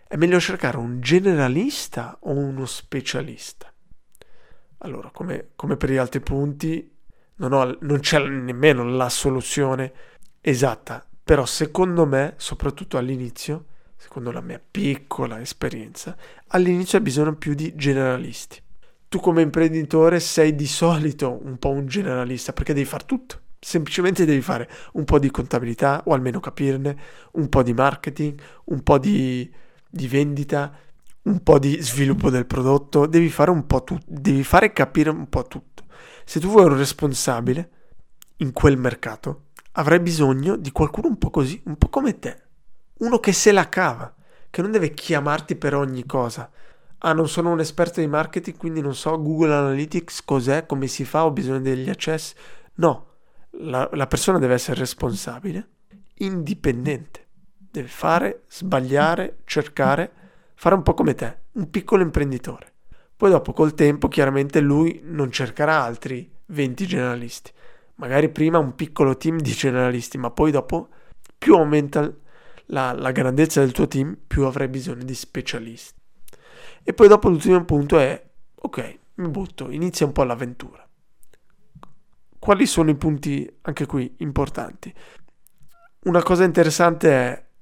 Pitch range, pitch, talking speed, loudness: 135-170 Hz, 150 Hz, 150 wpm, -21 LUFS